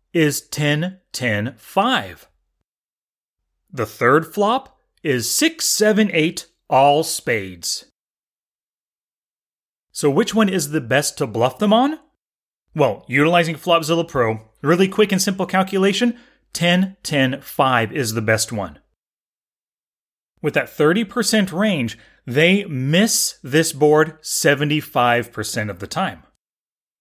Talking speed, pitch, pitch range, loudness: 115 wpm, 160 Hz, 130-195 Hz, -18 LUFS